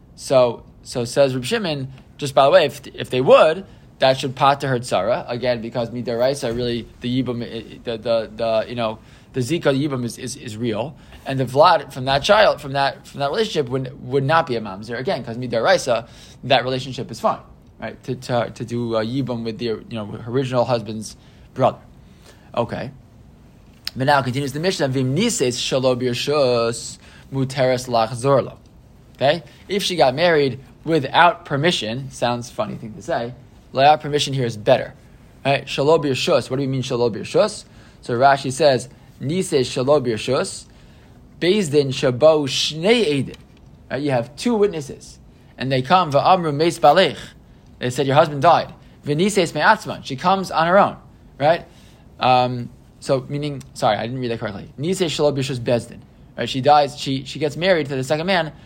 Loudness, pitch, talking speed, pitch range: -19 LUFS, 135 Hz, 170 wpm, 120-150 Hz